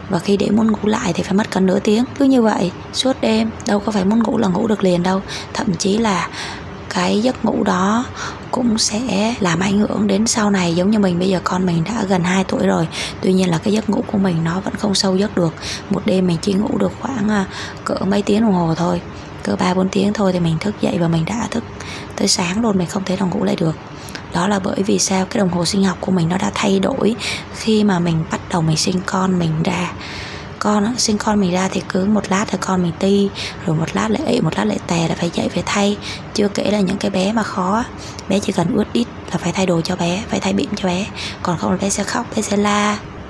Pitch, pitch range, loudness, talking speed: 195 Hz, 185-215 Hz, -18 LUFS, 265 wpm